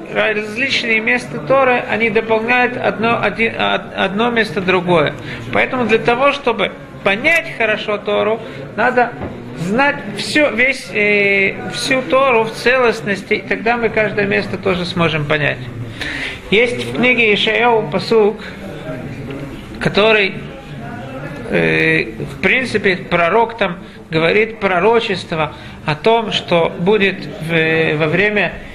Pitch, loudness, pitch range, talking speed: 210 Hz, -15 LUFS, 170-230 Hz, 115 wpm